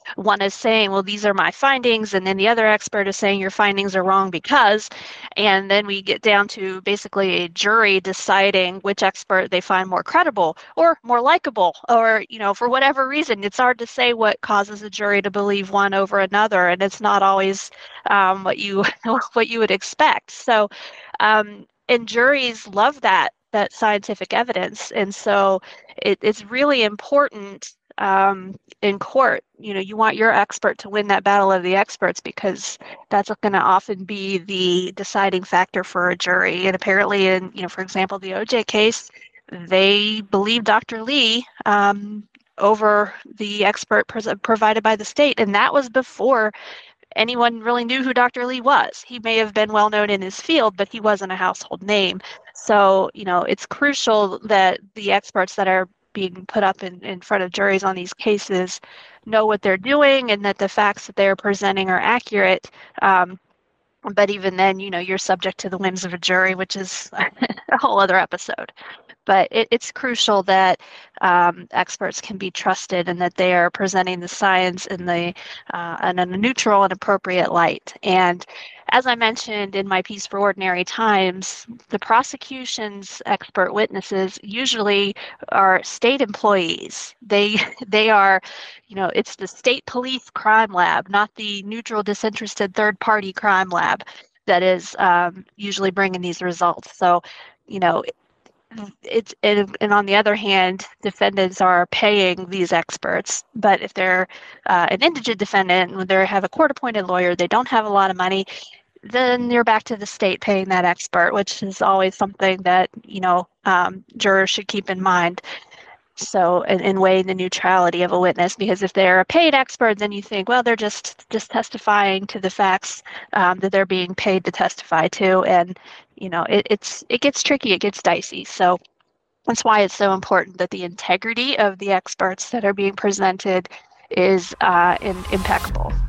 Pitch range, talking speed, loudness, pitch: 190-220 Hz, 180 wpm, -18 LUFS, 200 Hz